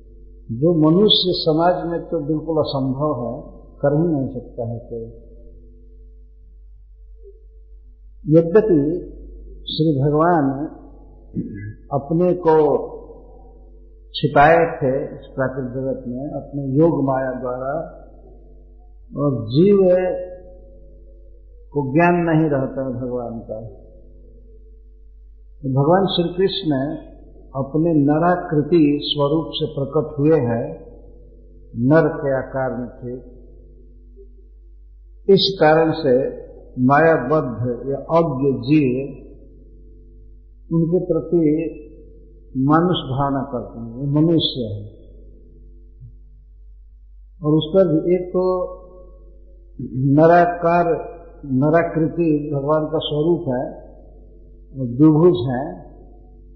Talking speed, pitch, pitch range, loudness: 90 wpm, 140 Hz, 115-160 Hz, -18 LUFS